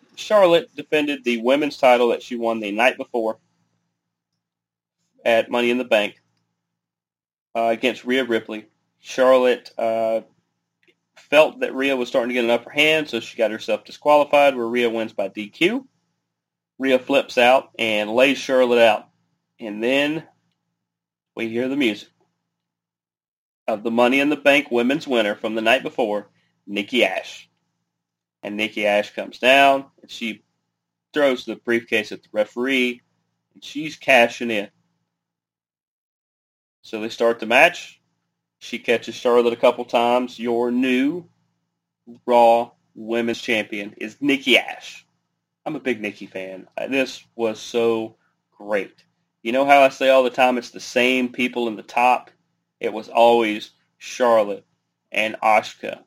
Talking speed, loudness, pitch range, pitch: 145 wpm, -20 LUFS, 115-135 Hz, 120 Hz